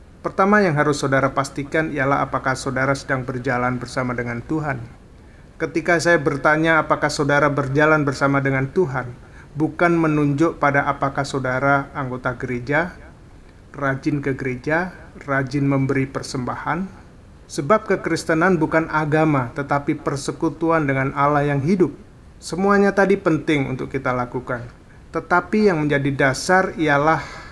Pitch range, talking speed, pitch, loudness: 130-160 Hz, 120 wpm, 145 Hz, -20 LUFS